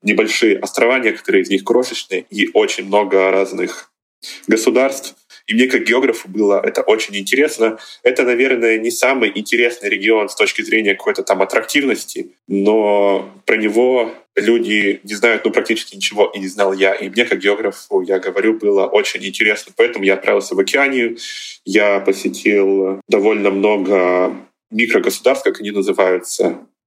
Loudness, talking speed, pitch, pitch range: -15 LUFS, 145 wpm, 110 Hz, 100-135 Hz